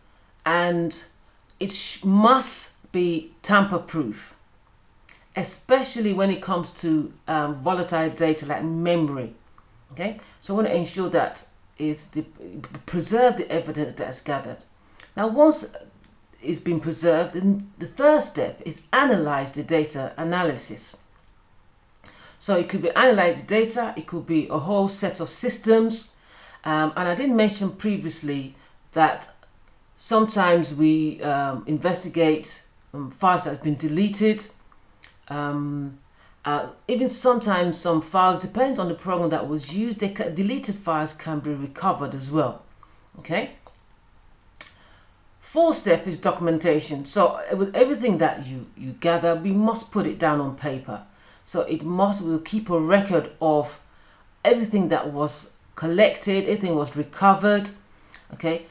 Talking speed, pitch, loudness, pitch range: 135 wpm, 170 Hz, -23 LUFS, 150-195 Hz